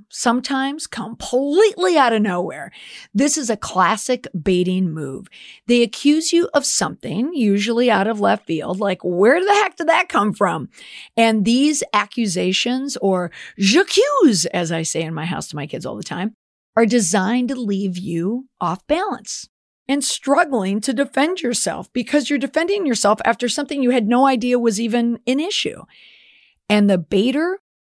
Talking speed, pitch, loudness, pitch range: 160 wpm, 235 Hz, -18 LUFS, 195-280 Hz